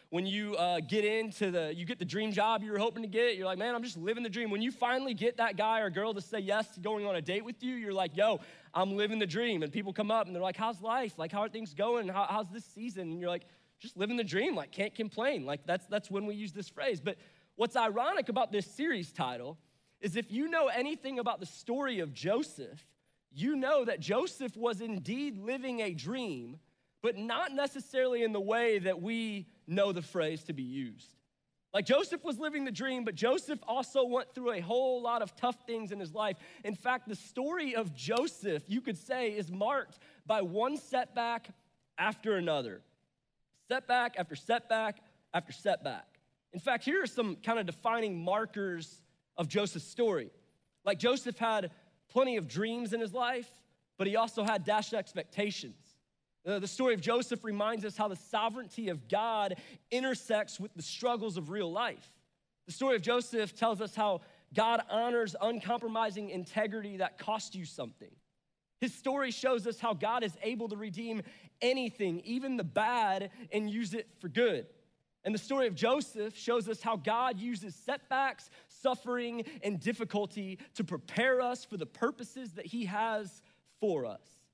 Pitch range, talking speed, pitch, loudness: 195-240 Hz, 190 wpm, 220 Hz, -34 LUFS